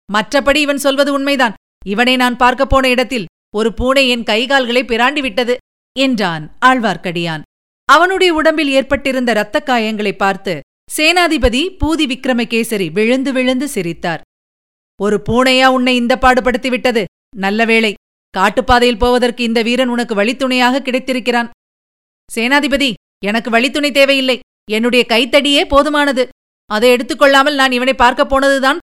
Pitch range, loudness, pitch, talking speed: 225-275 Hz, -13 LUFS, 255 Hz, 115 wpm